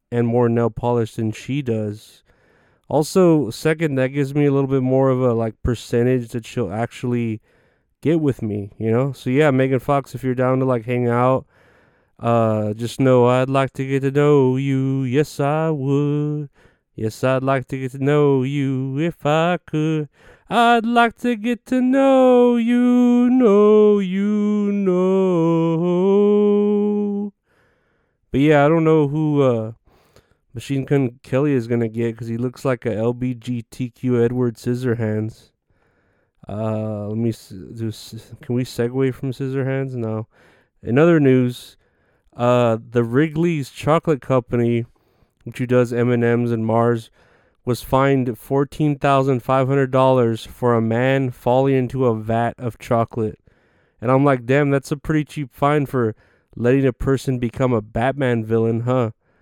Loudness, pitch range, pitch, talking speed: -19 LUFS, 115-145 Hz, 130 Hz, 155 wpm